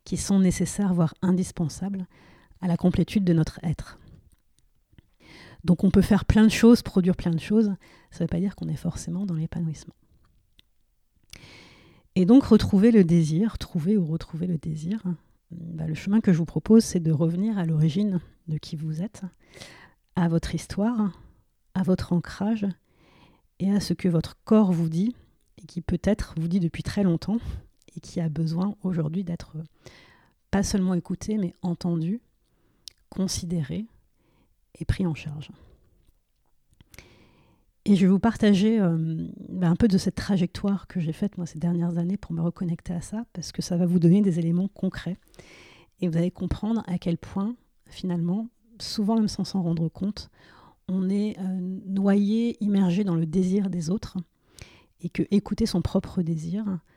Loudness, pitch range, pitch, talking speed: -25 LUFS, 170-200 Hz, 180 Hz, 165 wpm